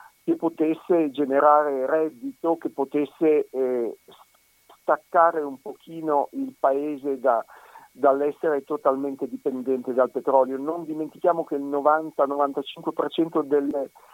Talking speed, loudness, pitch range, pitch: 100 wpm, -24 LUFS, 140-160 Hz, 145 Hz